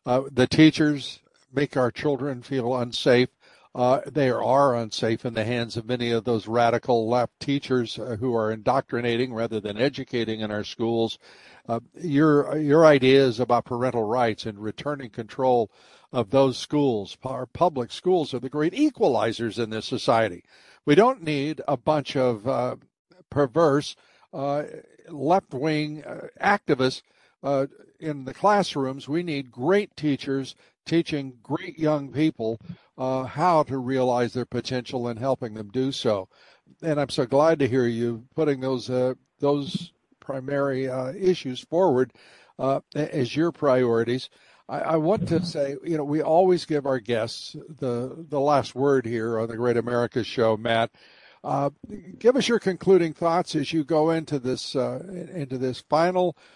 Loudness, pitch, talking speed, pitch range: -24 LUFS, 135 Hz, 155 wpm, 120-150 Hz